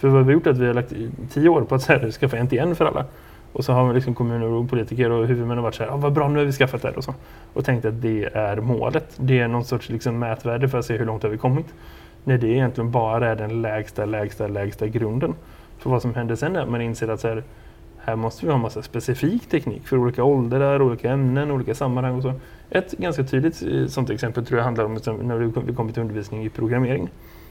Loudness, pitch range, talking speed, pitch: -22 LUFS, 115-130 Hz, 255 wpm, 120 Hz